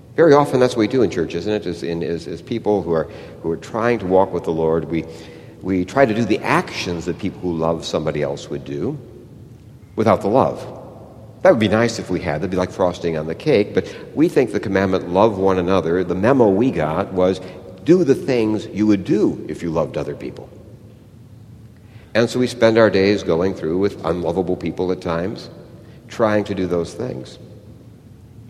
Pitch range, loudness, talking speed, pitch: 90-115 Hz, -19 LUFS, 210 wpm, 100 Hz